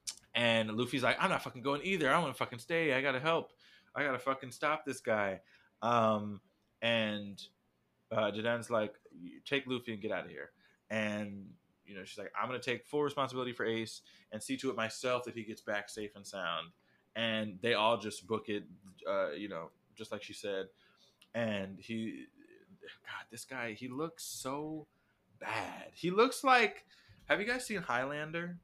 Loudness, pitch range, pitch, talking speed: -35 LUFS, 110-140 Hz, 120 Hz, 185 wpm